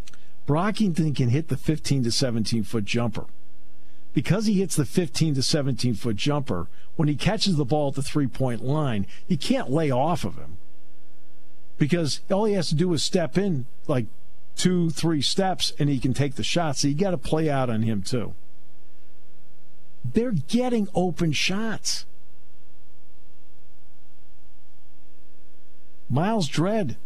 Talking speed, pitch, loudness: 150 wpm, 130 Hz, -25 LUFS